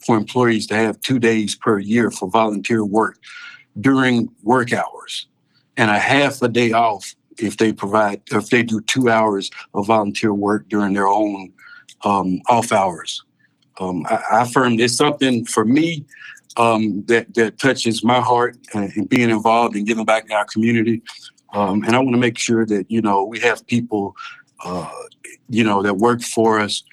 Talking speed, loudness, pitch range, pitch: 180 wpm, -18 LUFS, 105-120 Hz, 115 Hz